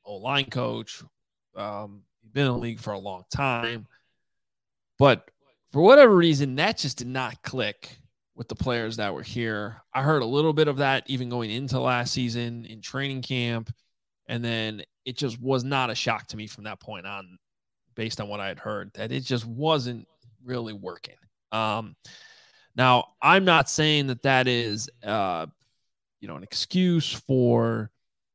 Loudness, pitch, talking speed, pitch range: -24 LUFS, 120 Hz, 175 wpm, 110-135 Hz